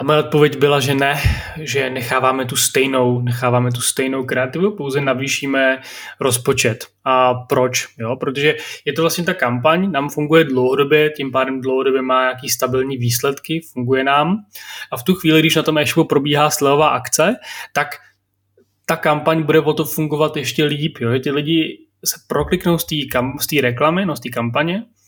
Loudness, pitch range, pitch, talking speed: -17 LUFS, 130-155 Hz, 140 Hz, 165 wpm